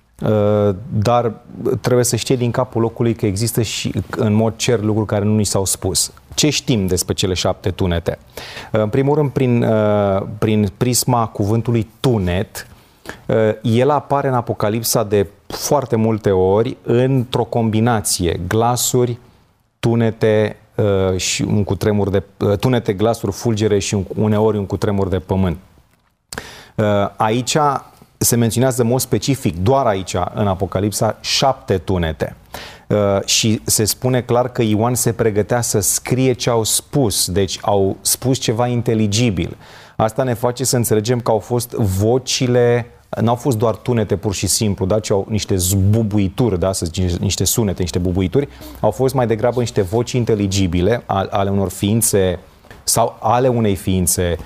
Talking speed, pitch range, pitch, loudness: 150 wpm, 100-120 Hz, 110 Hz, -17 LUFS